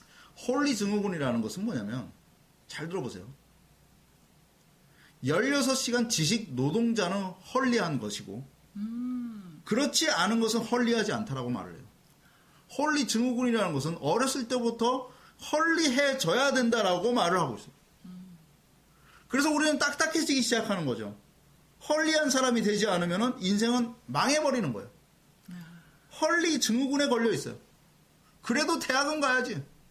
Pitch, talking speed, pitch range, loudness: 230 Hz, 285 characters per minute, 175-265 Hz, -28 LUFS